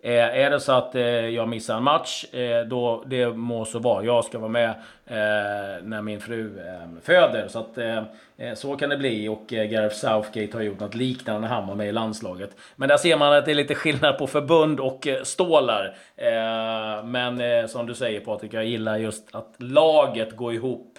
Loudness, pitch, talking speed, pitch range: -23 LUFS, 115 Hz, 210 wpm, 110-130 Hz